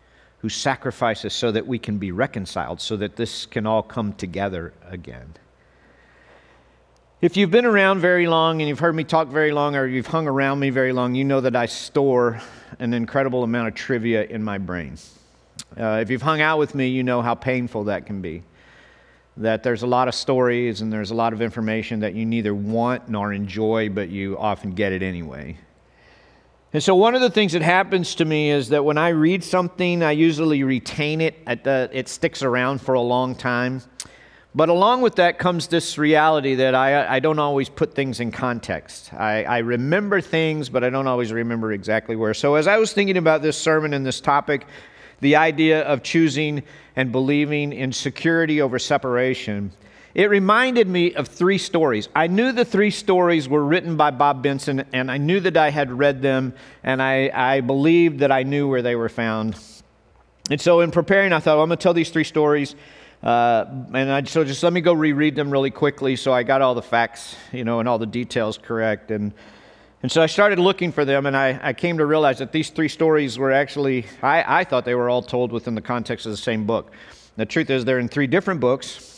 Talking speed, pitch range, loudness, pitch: 210 wpm, 115-155 Hz, -20 LUFS, 135 Hz